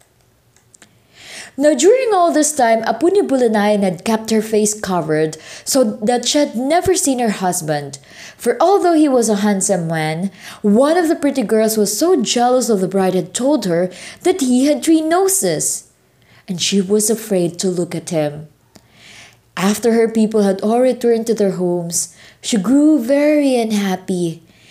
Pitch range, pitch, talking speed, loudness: 185-270 Hz, 220 Hz, 165 wpm, -15 LUFS